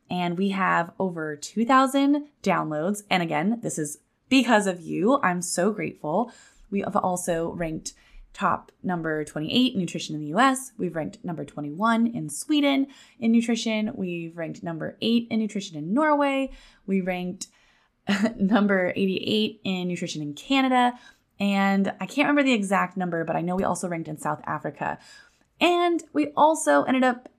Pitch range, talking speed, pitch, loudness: 175-255 Hz, 160 wpm, 200 Hz, -25 LUFS